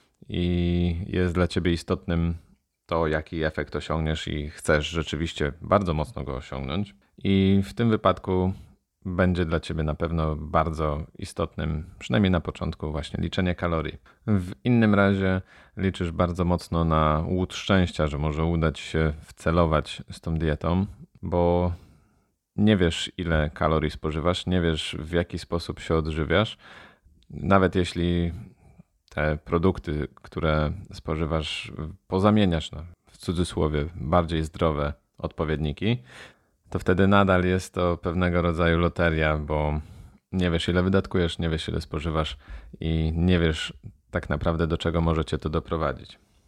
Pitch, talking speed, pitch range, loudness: 85 Hz, 135 wpm, 80-90 Hz, -26 LUFS